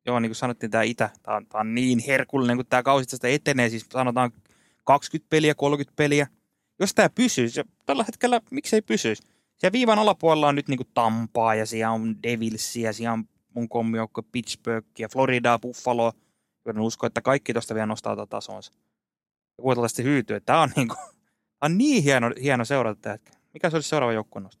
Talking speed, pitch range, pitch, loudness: 185 wpm, 110-145 Hz, 120 Hz, -24 LUFS